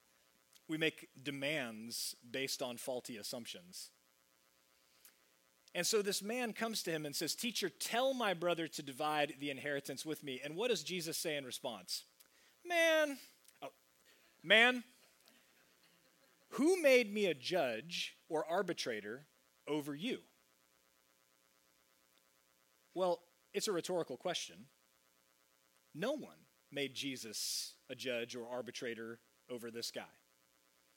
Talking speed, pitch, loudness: 120 wpm, 130 Hz, -38 LUFS